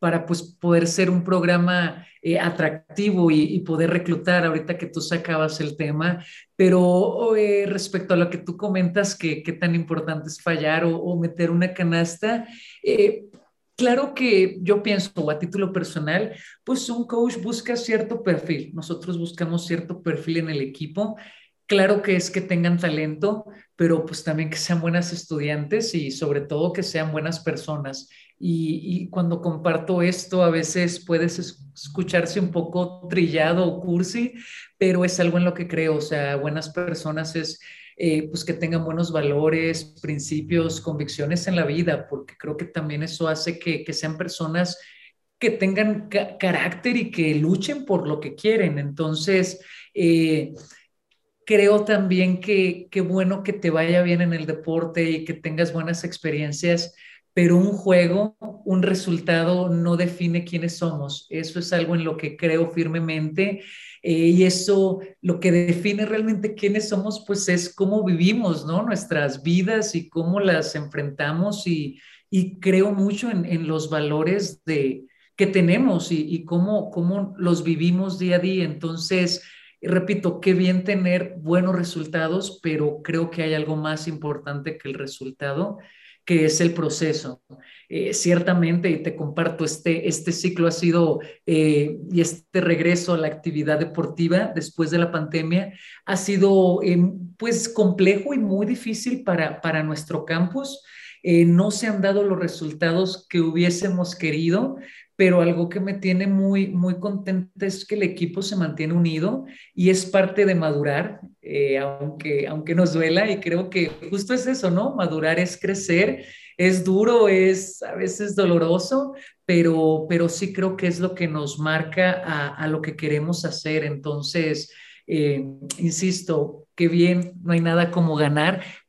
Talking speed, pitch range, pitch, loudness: 160 wpm, 160-190 Hz, 175 Hz, -22 LUFS